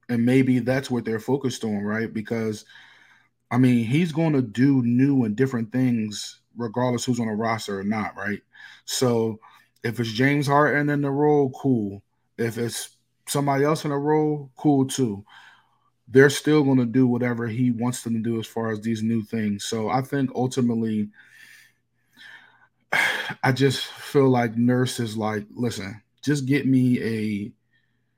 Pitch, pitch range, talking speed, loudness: 120 Hz, 115-135 Hz, 165 wpm, -23 LUFS